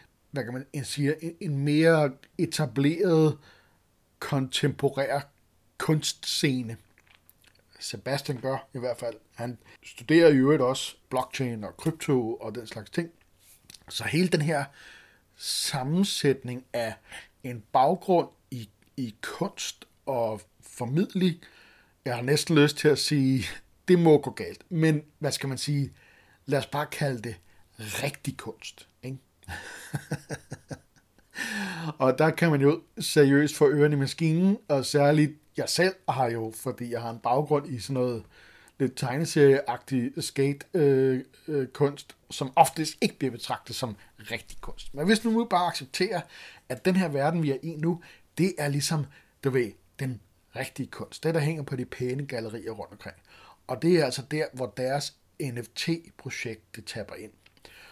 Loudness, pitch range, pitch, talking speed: -27 LUFS, 120-155 Hz, 135 Hz, 145 wpm